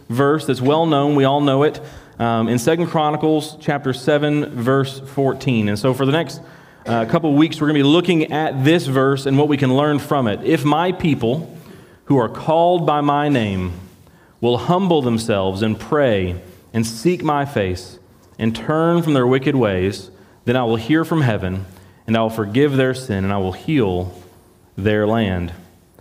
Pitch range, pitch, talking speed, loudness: 110-150 Hz, 135 Hz, 190 wpm, -18 LUFS